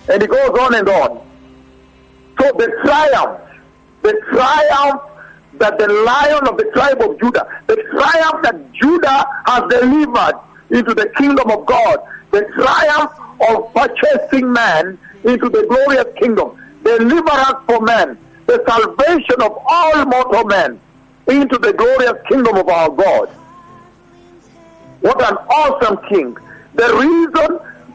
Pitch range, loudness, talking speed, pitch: 225-320 Hz, -13 LUFS, 130 wpm, 275 Hz